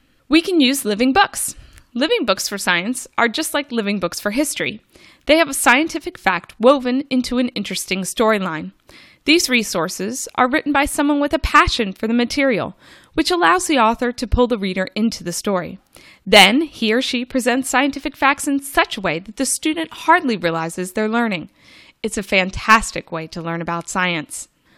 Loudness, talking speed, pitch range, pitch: -18 LUFS, 180 wpm, 200-285 Hz, 245 Hz